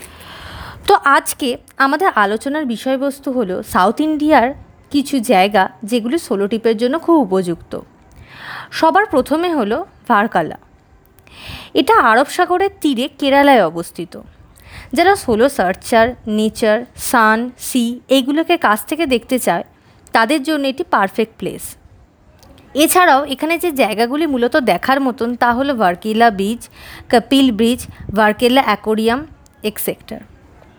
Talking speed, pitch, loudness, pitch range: 115 wpm, 255 Hz, -15 LUFS, 225-300 Hz